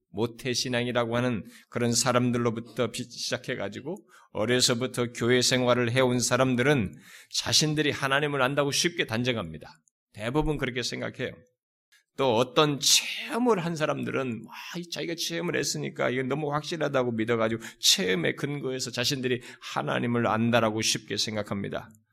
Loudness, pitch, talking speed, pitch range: -26 LUFS, 125 Hz, 350 characters per minute, 120-145 Hz